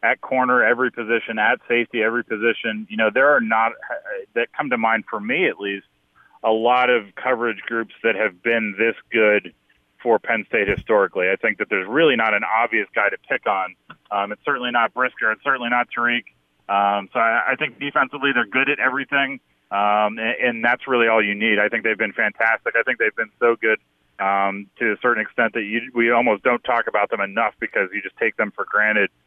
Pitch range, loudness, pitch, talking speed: 110-125 Hz, -20 LUFS, 115 Hz, 215 wpm